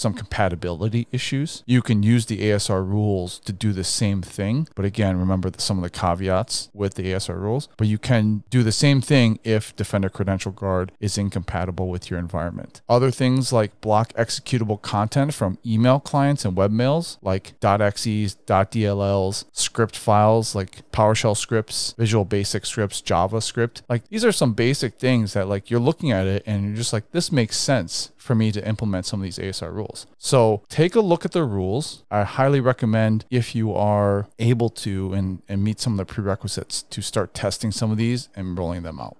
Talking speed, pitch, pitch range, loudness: 190 wpm, 110 Hz, 100-120 Hz, -22 LUFS